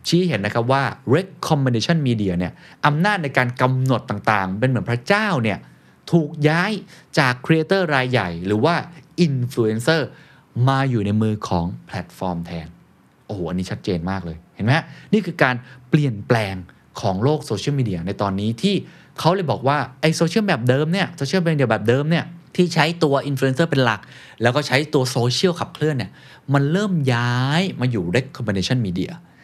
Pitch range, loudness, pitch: 110-160 Hz, -20 LUFS, 130 Hz